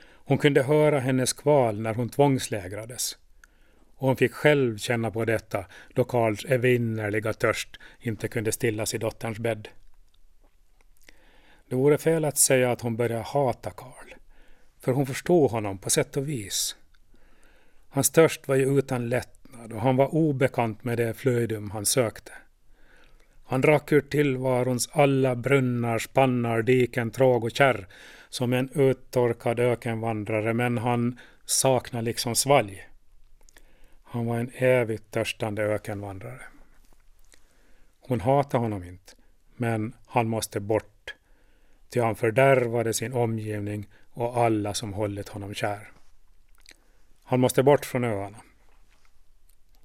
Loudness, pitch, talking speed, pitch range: -25 LUFS, 120 Hz, 130 wpm, 110-130 Hz